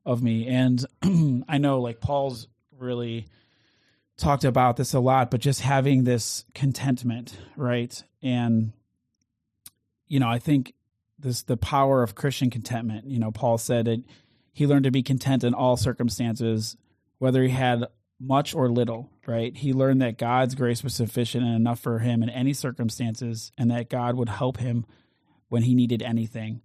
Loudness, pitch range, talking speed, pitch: -25 LUFS, 115-130 Hz, 165 wpm, 120 Hz